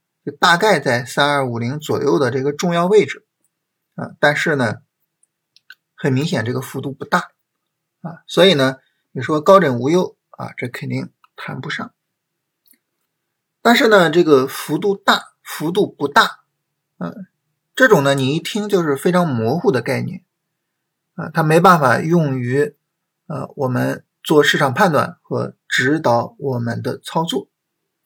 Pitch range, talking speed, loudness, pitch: 140-180 Hz, 210 characters per minute, -17 LUFS, 160 Hz